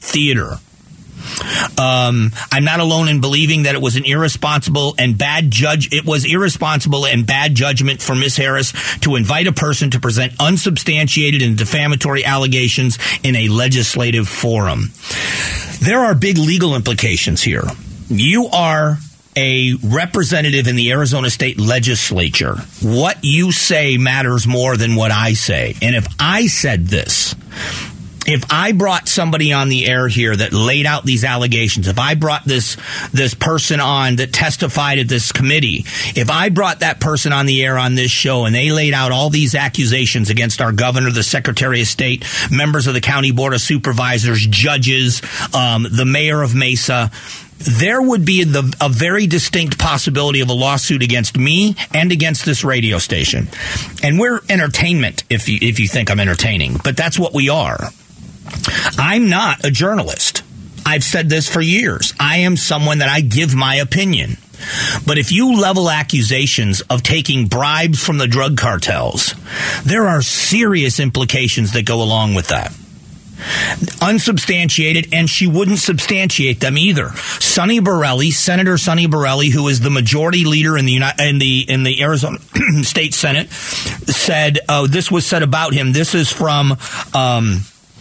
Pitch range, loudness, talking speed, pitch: 125-155 Hz, -14 LUFS, 165 wpm, 140 Hz